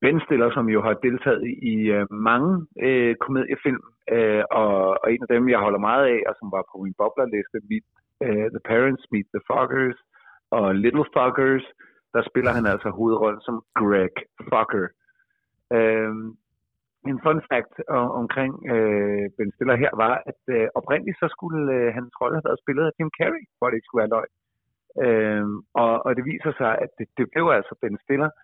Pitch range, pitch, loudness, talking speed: 110-140 Hz, 120 Hz, -23 LUFS, 185 wpm